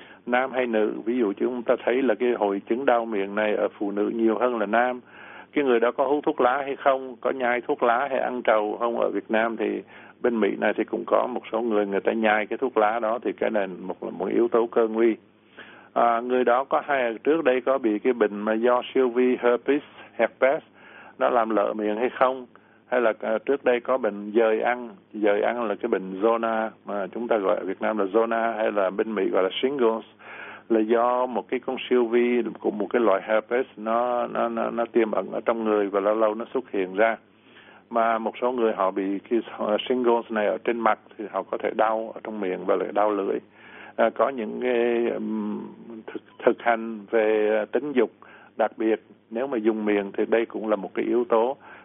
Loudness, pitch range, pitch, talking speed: -24 LUFS, 110-125 Hz, 115 Hz, 230 wpm